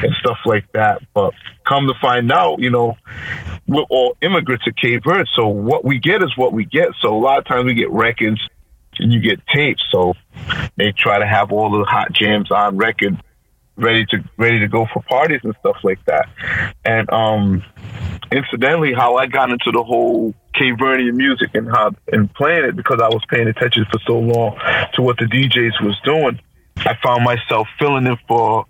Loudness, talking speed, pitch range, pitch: -16 LUFS, 200 wpm, 110-130 Hz, 115 Hz